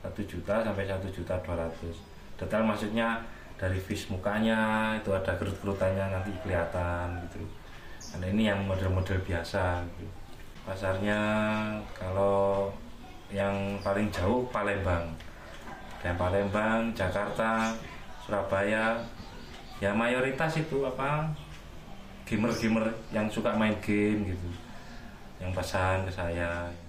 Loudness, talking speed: -30 LUFS, 110 wpm